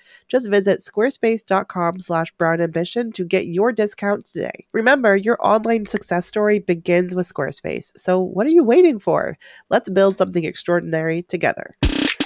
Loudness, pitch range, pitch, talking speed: -19 LUFS, 175-220 Hz, 195 Hz, 145 wpm